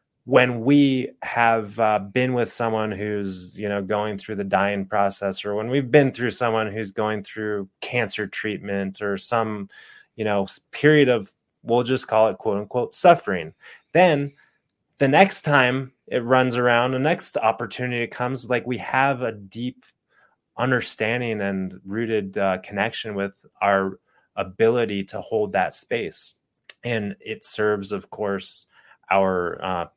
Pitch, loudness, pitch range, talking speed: 110 Hz, -22 LUFS, 100-125 Hz, 150 wpm